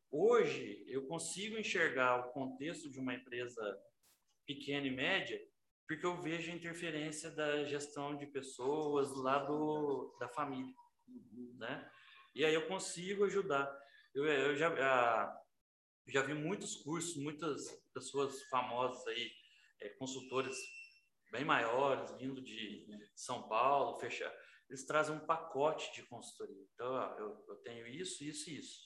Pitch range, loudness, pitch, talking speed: 135-180 Hz, -39 LUFS, 150 Hz, 135 wpm